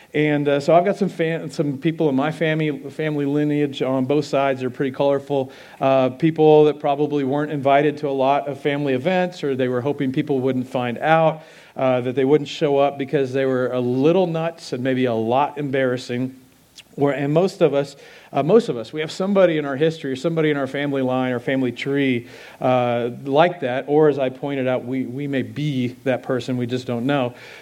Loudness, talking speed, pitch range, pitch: -20 LUFS, 215 wpm, 130-150 Hz, 140 Hz